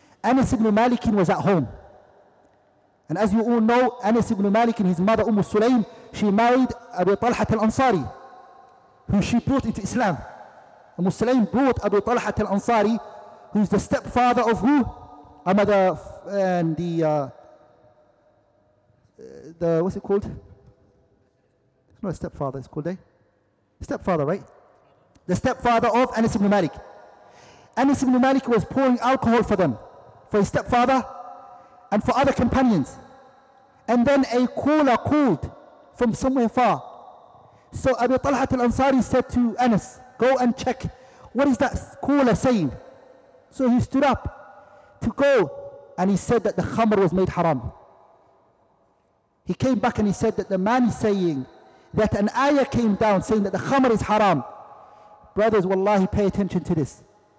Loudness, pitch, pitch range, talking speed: -22 LUFS, 225 Hz, 190-250 Hz, 155 wpm